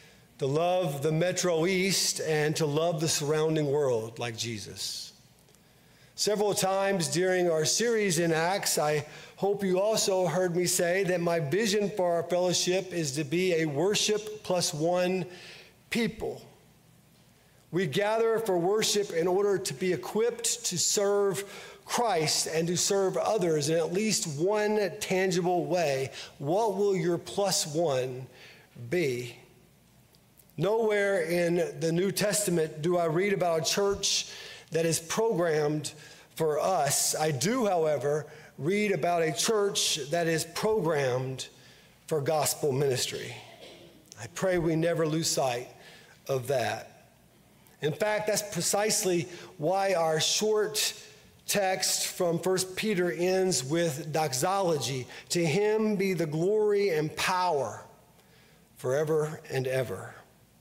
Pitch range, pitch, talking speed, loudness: 155-195 Hz, 175 Hz, 130 wpm, -28 LUFS